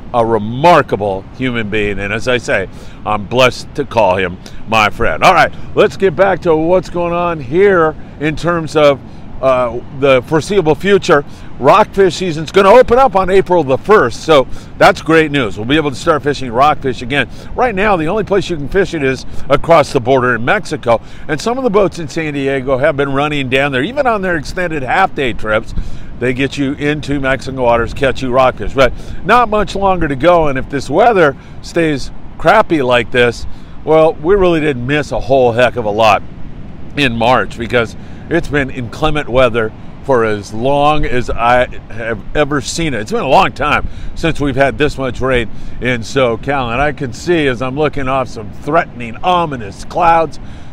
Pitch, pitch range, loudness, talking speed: 140 Hz, 125-165 Hz, -13 LUFS, 195 wpm